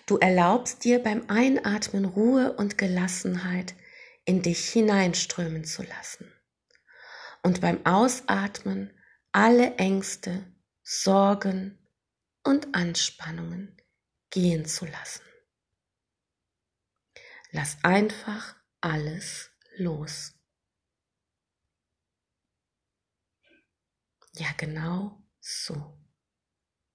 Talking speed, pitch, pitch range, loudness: 70 wpm, 180 Hz, 150-205 Hz, -26 LUFS